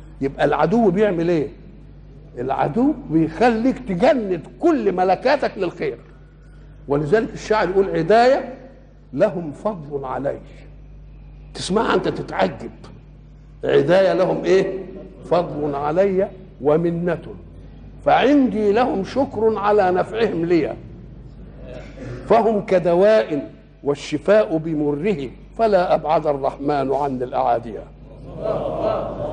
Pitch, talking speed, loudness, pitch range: 185 Hz, 85 wpm, -19 LUFS, 150-215 Hz